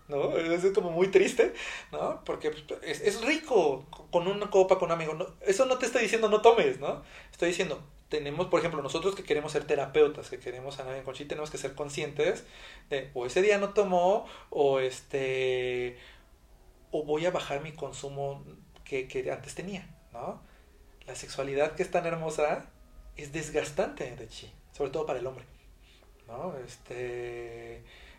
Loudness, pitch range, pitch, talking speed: -30 LUFS, 135-195 Hz, 155 Hz, 170 wpm